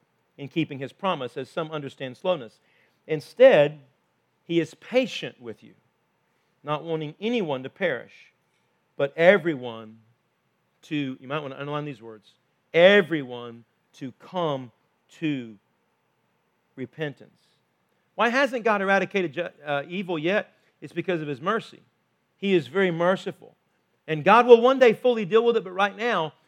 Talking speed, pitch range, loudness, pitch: 140 wpm, 140-195 Hz, -24 LUFS, 160 Hz